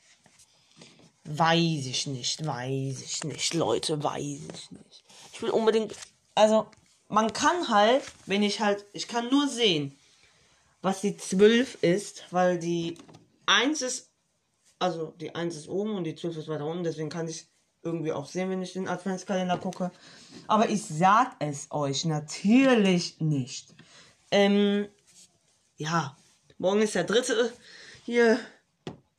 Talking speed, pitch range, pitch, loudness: 140 wpm, 155-210 Hz, 180 Hz, -27 LUFS